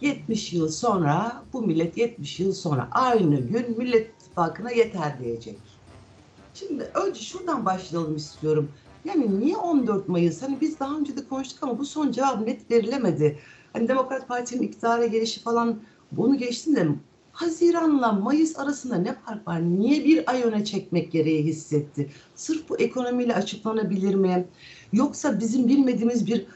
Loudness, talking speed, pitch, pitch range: -25 LUFS, 150 wpm, 230 Hz, 175-265 Hz